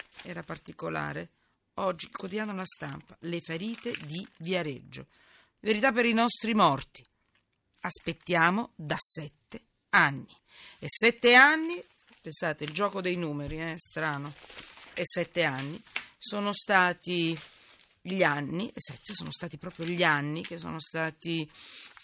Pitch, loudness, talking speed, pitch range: 175 Hz, -27 LUFS, 125 wpm, 155-205 Hz